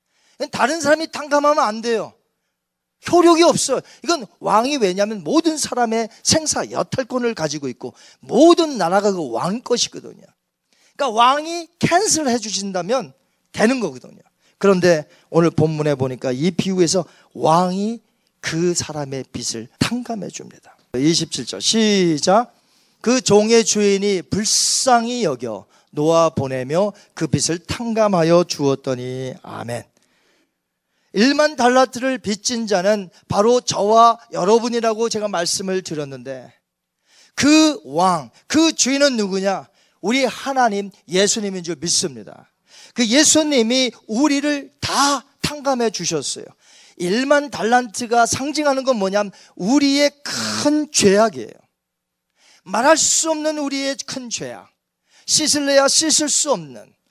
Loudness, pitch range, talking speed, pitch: -18 LUFS, 175-265 Hz, 260 characters per minute, 220 Hz